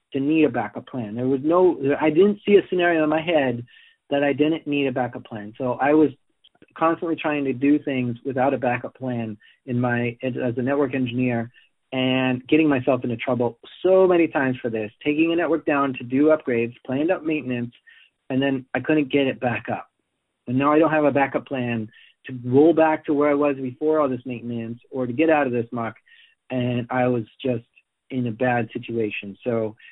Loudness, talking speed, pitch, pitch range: -22 LUFS, 210 wpm, 130 Hz, 120-155 Hz